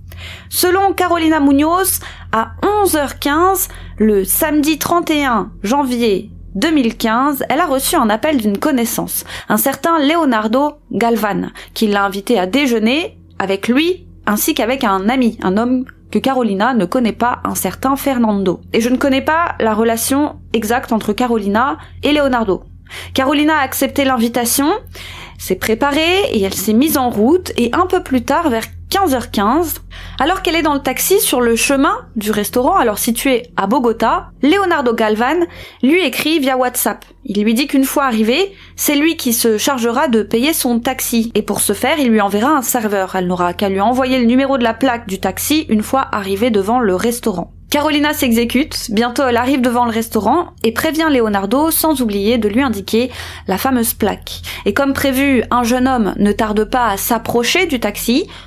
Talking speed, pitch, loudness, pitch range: 170 wpm, 250 Hz, -15 LUFS, 220-290 Hz